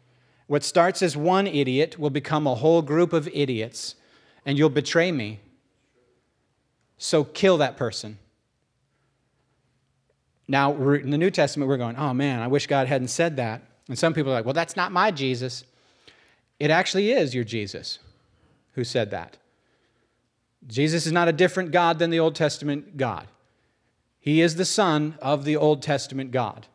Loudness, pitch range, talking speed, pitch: -23 LUFS, 125-160 Hz, 165 wpm, 140 Hz